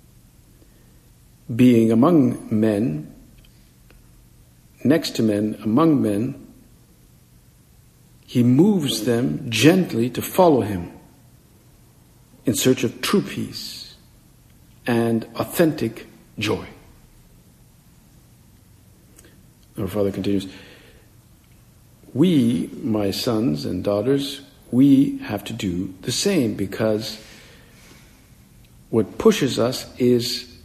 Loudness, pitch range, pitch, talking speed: -20 LUFS, 100-125 Hz, 110 Hz, 80 wpm